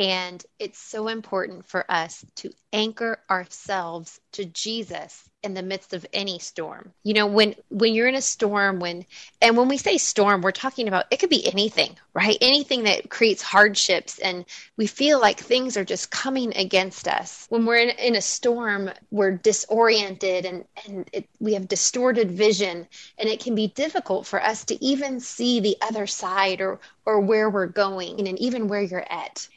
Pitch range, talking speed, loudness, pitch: 190-230 Hz, 185 wpm, -22 LUFS, 210 Hz